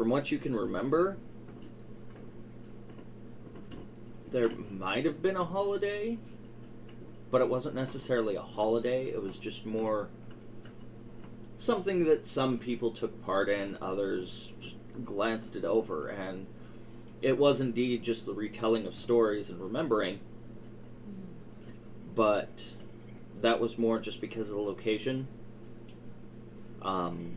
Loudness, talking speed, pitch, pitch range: -32 LUFS, 120 wpm, 115 Hz, 110-120 Hz